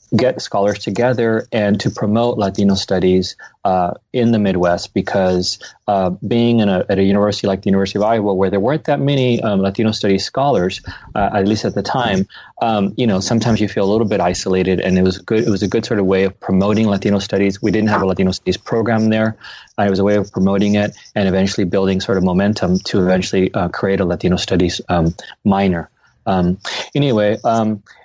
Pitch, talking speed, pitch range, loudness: 100 Hz, 210 wpm, 95-110 Hz, -16 LUFS